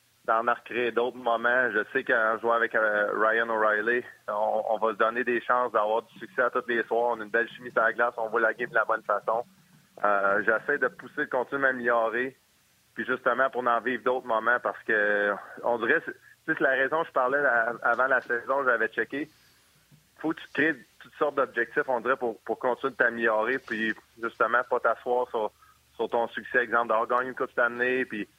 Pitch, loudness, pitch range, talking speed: 115 Hz, -27 LUFS, 110-125 Hz, 210 wpm